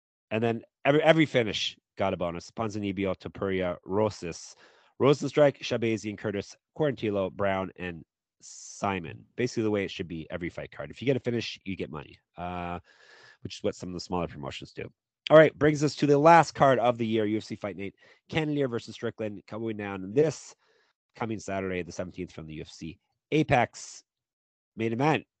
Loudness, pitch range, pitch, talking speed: -28 LUFS, 90-125 Hz, 110 Hz, 180 wpm